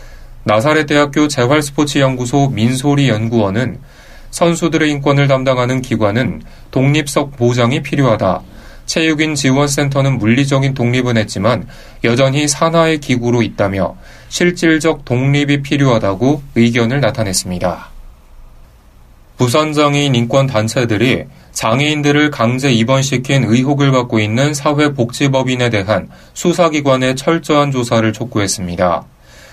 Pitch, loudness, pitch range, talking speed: 130 Hz, -14 LUFS, 115-145 Hz, 305 characters per minute